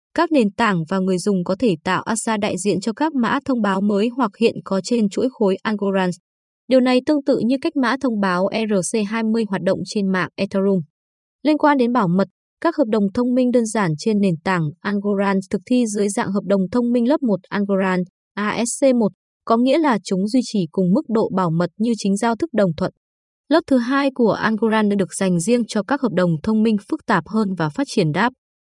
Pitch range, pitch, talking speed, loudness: 190-245 Hz, 215 Hz, 220 wpm, -19 LUFS